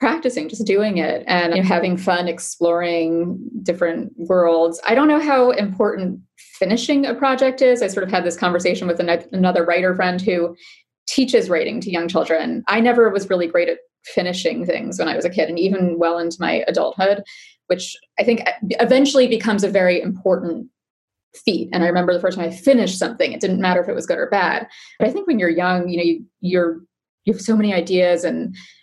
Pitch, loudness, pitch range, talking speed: 185 Hz, -18 LUFS, 175-235 Hz, 205 wpm